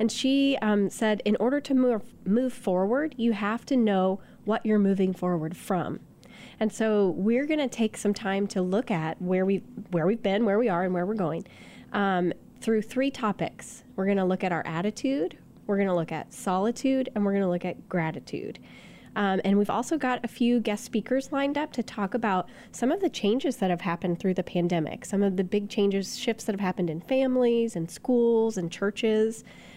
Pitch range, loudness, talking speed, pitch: 190-235 Hz, -27 LUFS, 210 wpm, 210 Hz